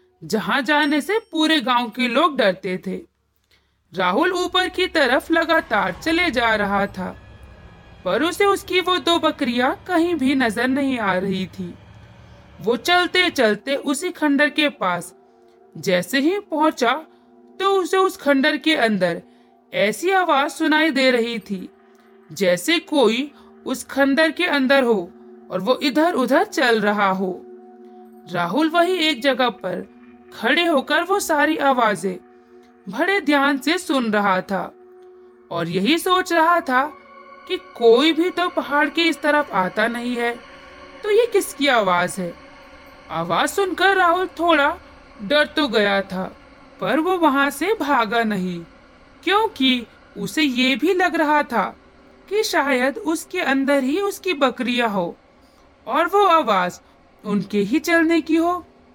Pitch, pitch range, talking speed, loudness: 280 Hz, 210-330 Hz, 140 wpm, -19 LUFS